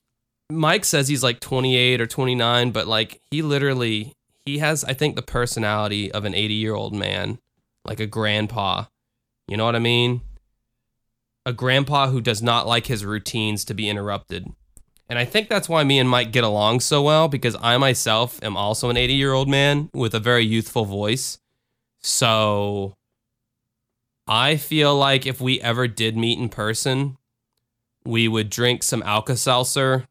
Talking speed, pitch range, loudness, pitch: 160 wpm, 110-130 Hz, -20 LUFS, 120 Hz